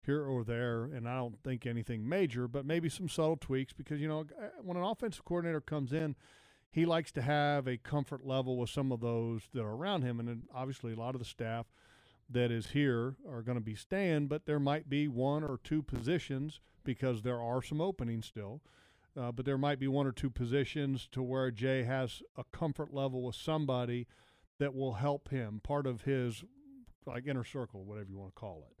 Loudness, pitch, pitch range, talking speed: -37 LUFS, 130 Hz, 120-150 Hz, 210 wpm